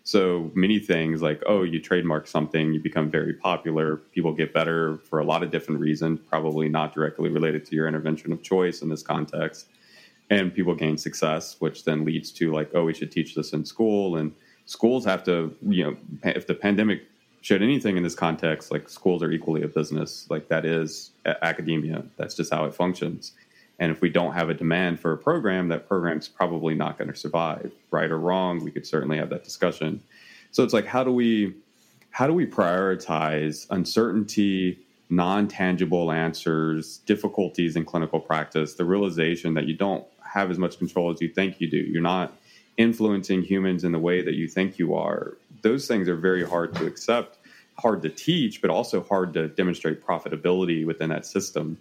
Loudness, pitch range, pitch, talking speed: -25 LUFS, 80-90 Hz, 85 Hz, 190 wpm